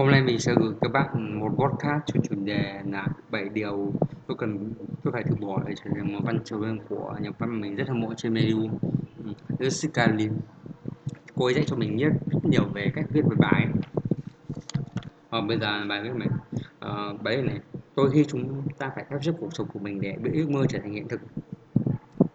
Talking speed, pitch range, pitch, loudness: 210 wpm, 105-135 Hz, 115 Hz, -27 LUFS